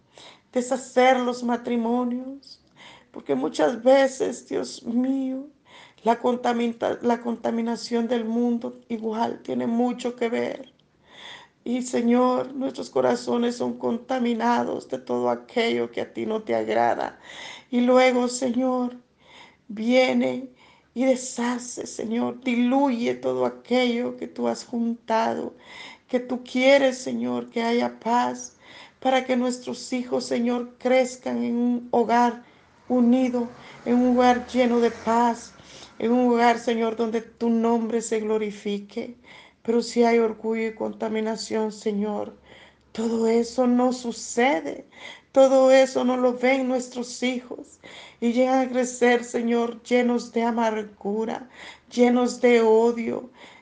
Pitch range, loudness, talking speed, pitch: 225-250 Hz, -24 LUFS, 120 wpm, 240 Hz